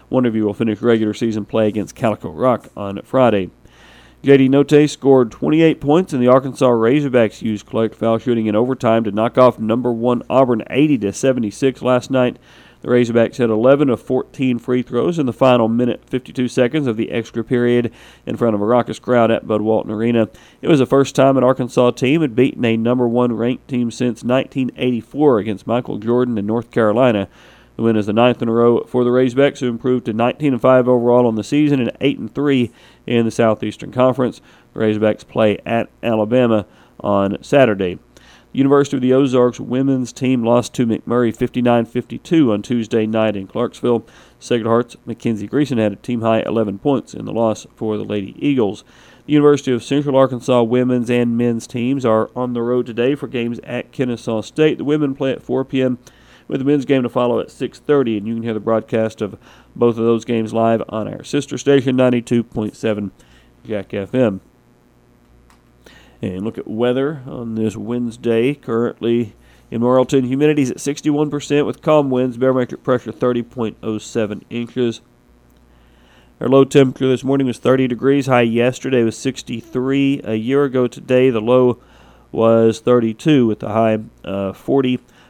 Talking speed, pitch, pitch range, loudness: 190 wpm, 120 Hz, 110-130 Hz, -17 LUFS